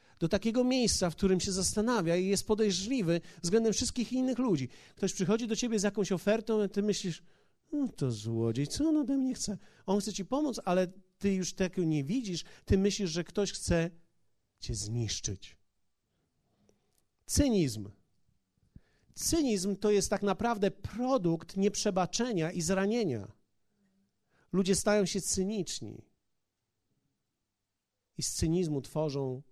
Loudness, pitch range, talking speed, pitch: -31 LUFS, 165-215 Hz, 135 wpm, 195 Hz